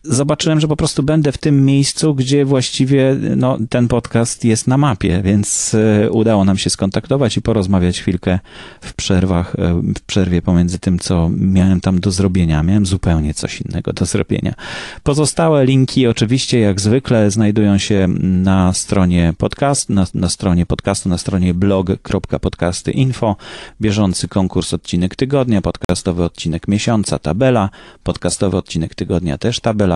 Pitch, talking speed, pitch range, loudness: 100 Hz, 140 wpm, 90-130 Hz, -15 LUFS